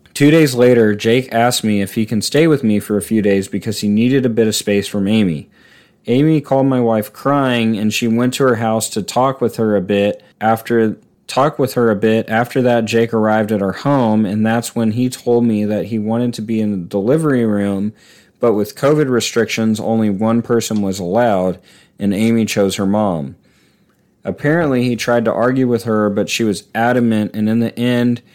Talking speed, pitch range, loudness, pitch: 210 wpm, 105-120 Hz, -15 LUFS, 115 Hz